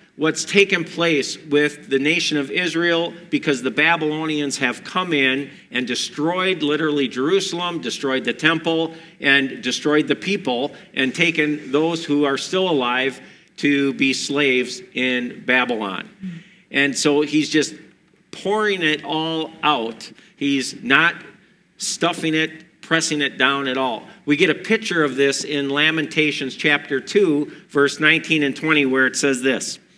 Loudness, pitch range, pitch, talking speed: -19 LUFS, 140-165 Hz, 150 Hz, 145 wpm